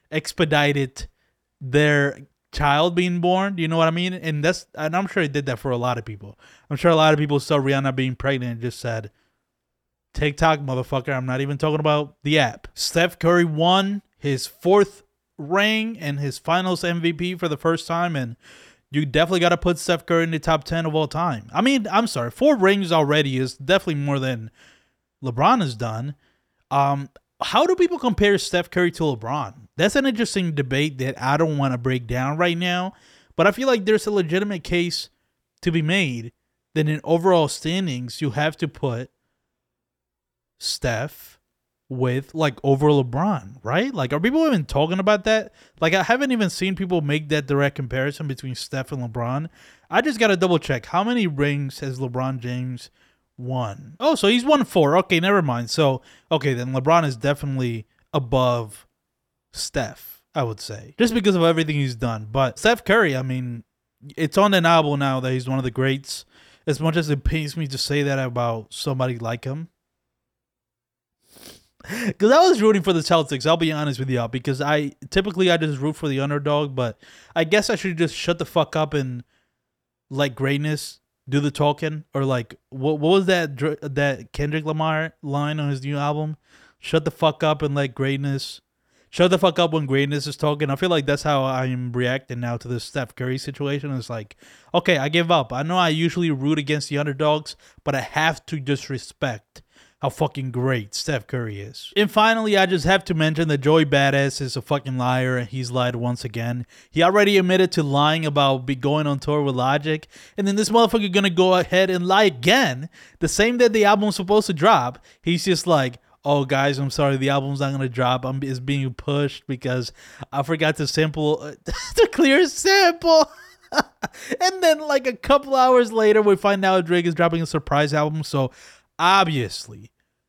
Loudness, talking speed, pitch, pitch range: -21 LUFS, 190 wpm, 150 Hz, 135-175 Hz